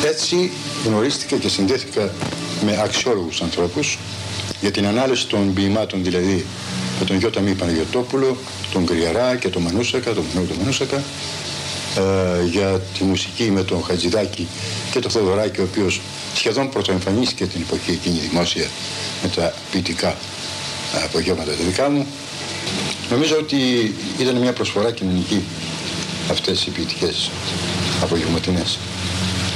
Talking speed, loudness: 125 wpm, -20 LUFS